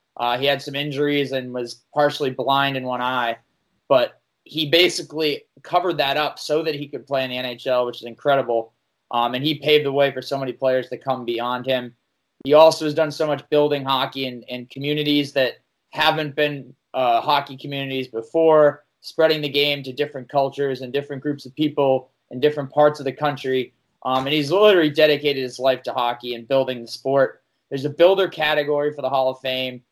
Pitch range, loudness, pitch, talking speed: 130-150 Hz, -21 LUFS, 140 Hz, 200 wpm